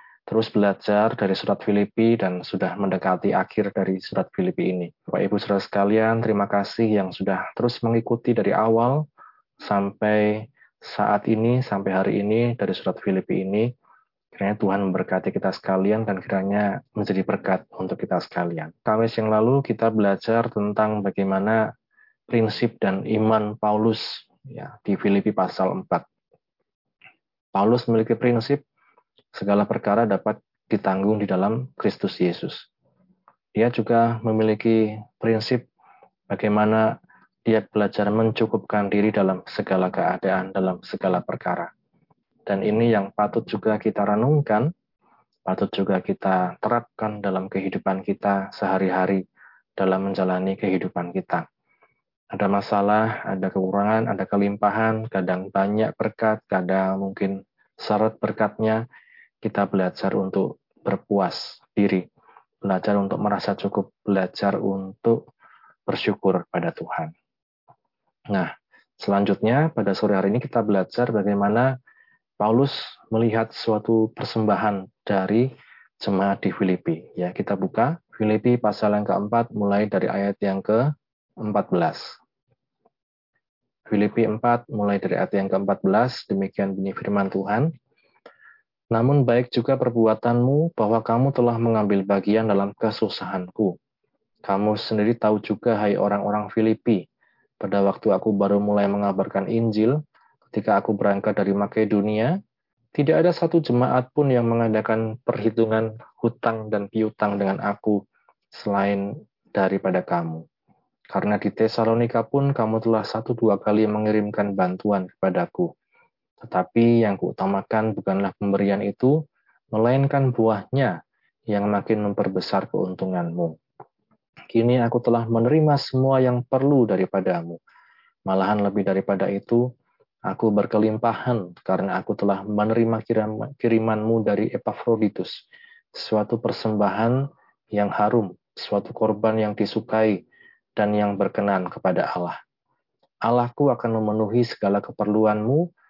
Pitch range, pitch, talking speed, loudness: 100-115 Hz, 105 Hz, 115 wpm, -23 LUFS